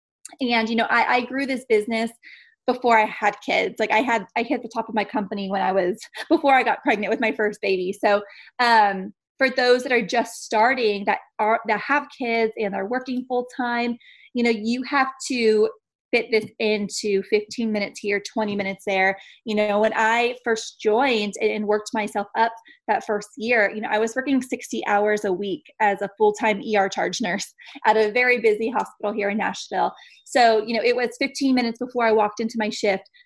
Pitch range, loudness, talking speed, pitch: 210-245 Hz, -22 LUFS, 205 wpm, 225 Hz